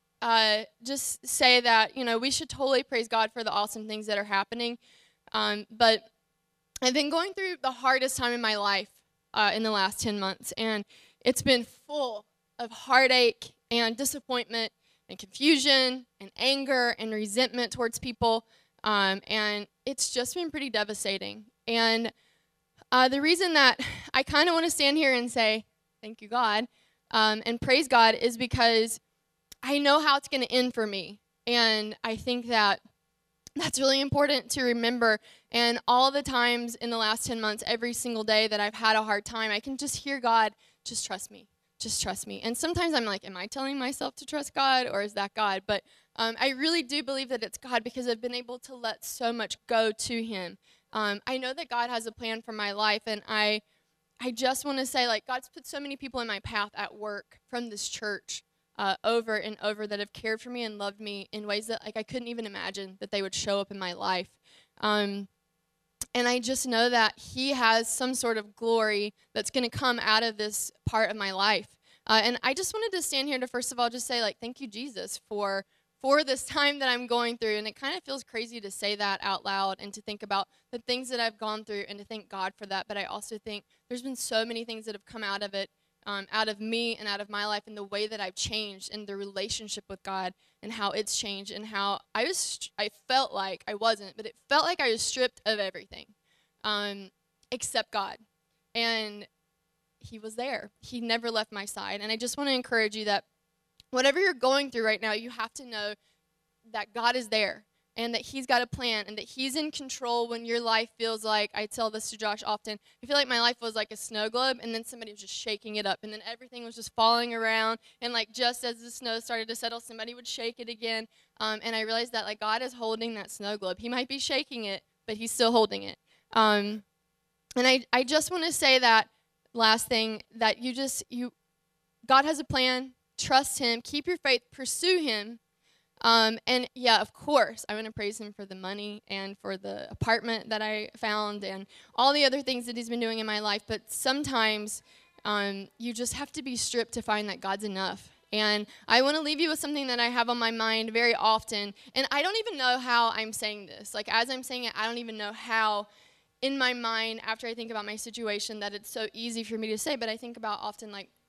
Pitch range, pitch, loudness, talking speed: 210-250 Hz, 225 Hz, -28 LUFS, 225 wpm